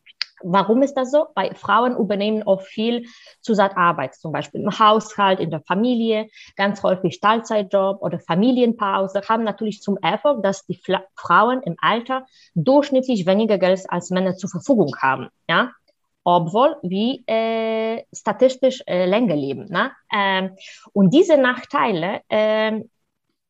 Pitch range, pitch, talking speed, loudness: 190-230 Hz, 210 Hz, 135 wpm, -20 LUFS